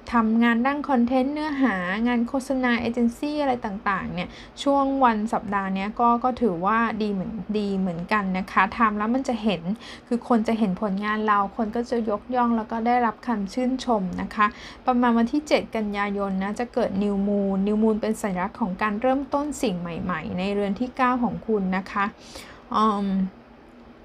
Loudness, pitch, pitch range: -24 LUFS, 225 Hz, 200-245 Hz